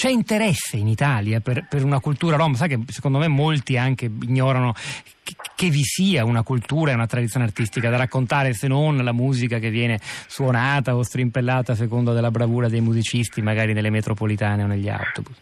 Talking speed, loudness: 190 wpm, -21 LUFS